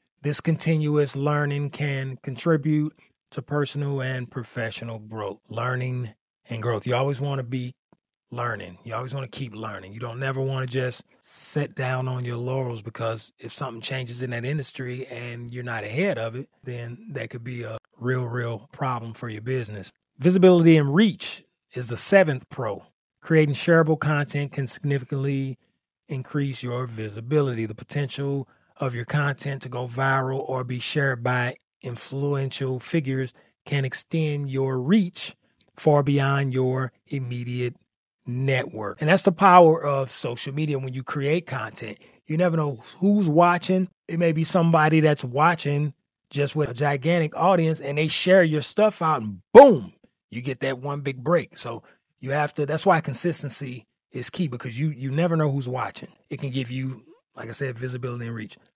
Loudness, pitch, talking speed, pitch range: -24 LUFS, 135 Hz, 170 wpm, 125-150 Hz